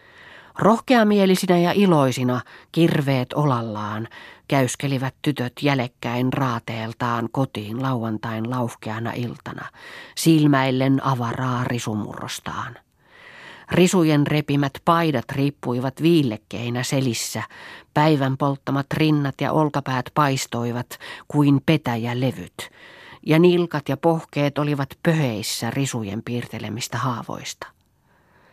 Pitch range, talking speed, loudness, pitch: 120-150 Hz, 85 wpm, -22 LUFS, 135 Hz